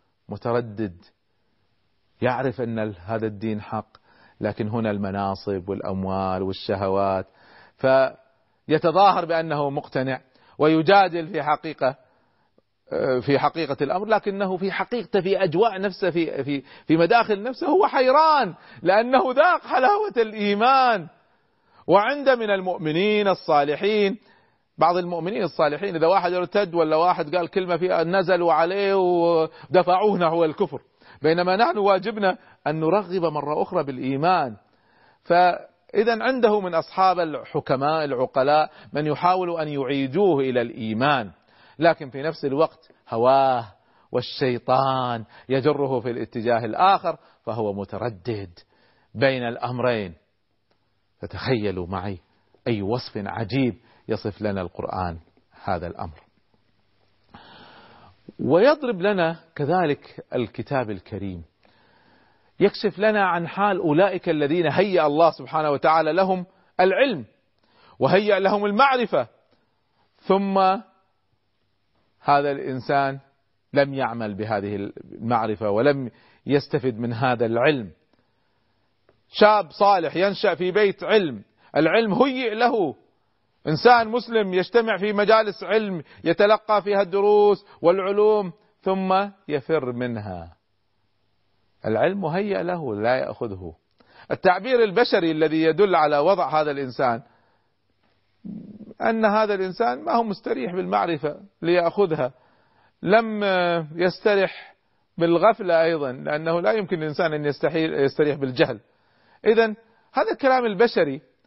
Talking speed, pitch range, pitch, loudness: 105 wpm, 120-195 Hz, 160 Hz, -22 LUFS